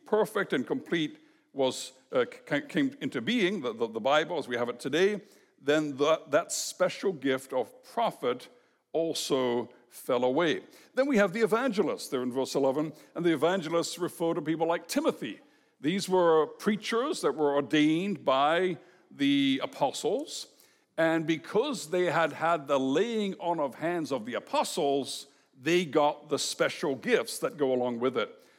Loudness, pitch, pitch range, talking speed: -29 LUFS, 165 Hz, 145-205 Hz, 160 wpm